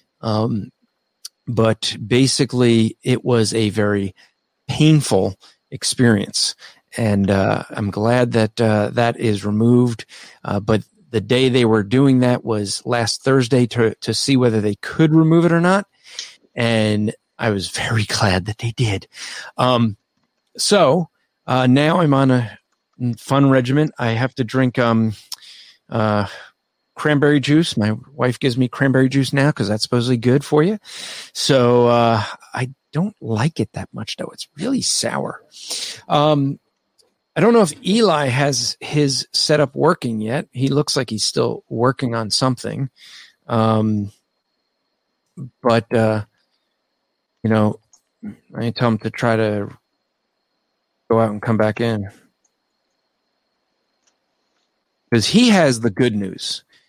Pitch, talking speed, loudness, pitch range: 120 Hz, 140 wpm, -18 LUFS, 110-135 Hz